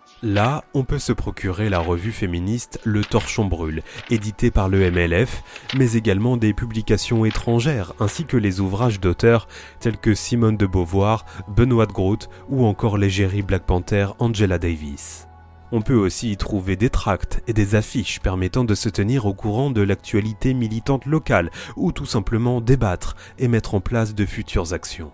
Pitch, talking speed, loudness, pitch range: 105 Hz, 170 wpm, -21 LUFS, 95-120 Hz